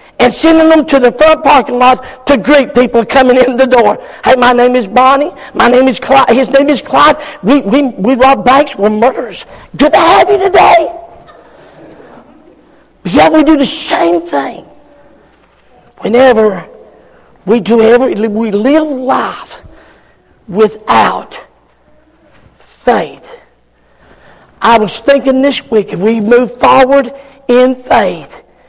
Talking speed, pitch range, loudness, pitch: 140 wpm, 235-280 Hz, -8 LUFS, 255 Hz